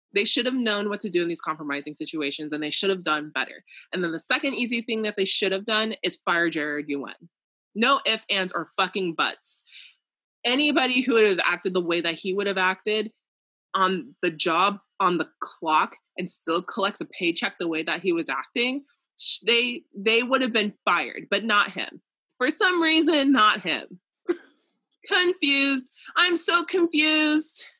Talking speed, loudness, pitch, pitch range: 185 wpm, -23 LUFS, 215 Hz, 180-275 Hz